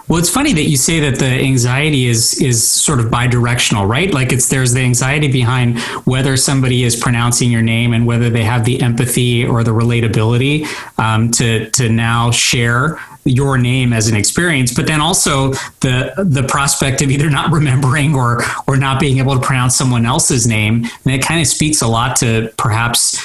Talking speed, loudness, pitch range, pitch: 195 wpm, -13 LUFS, 120-140 Hz, 130 Hz